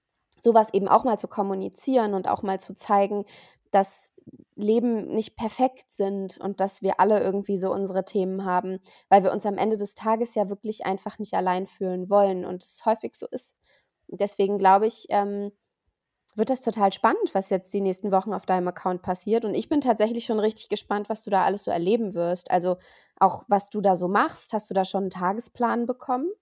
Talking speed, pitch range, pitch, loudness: 200 wpm, 190-220 Hz, 200 Hz, -25 LUFS